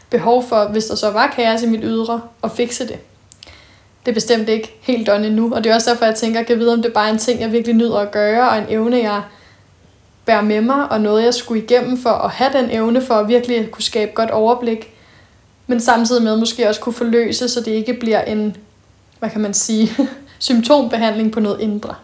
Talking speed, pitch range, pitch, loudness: 235 wpm, 215-240 Hz, 225 Hz, -16 LUFS